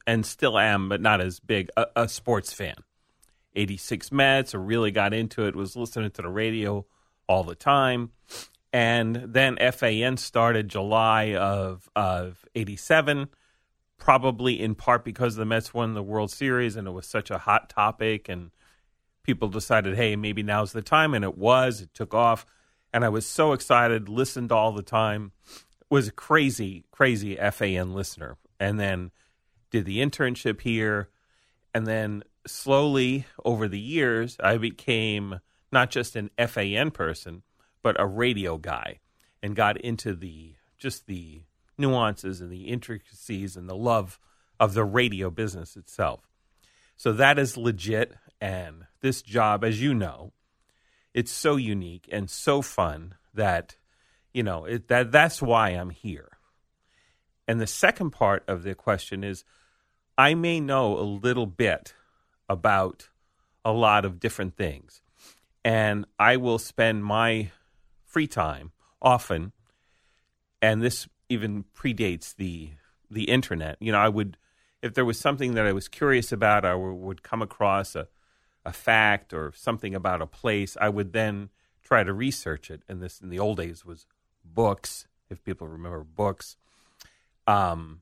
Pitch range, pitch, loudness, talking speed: 95-120 Hz, 110 Hz, -25 LUFS, 155 wpm